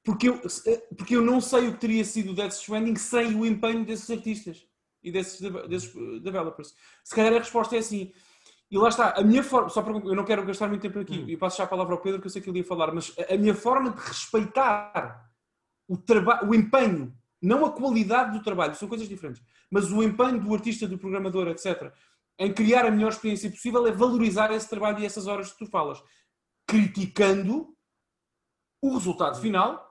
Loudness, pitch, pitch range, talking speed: -26 LUFS, 210 Hz, 190-230 Hz, 205 wpm